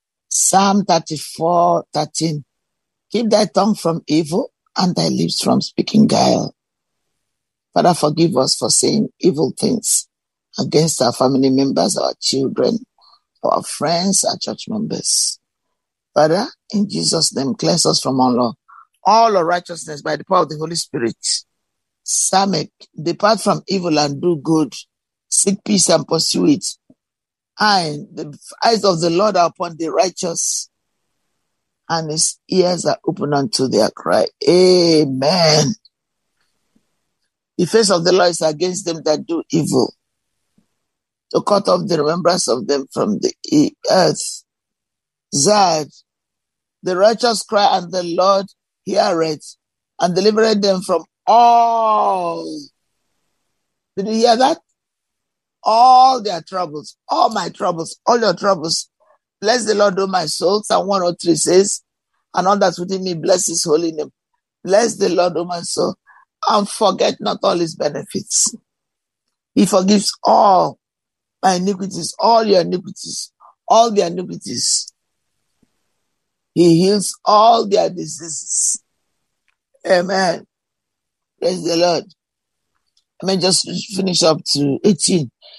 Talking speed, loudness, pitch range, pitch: 130 wpm, -16 LUFS, 165-205 Hz, 180 Hz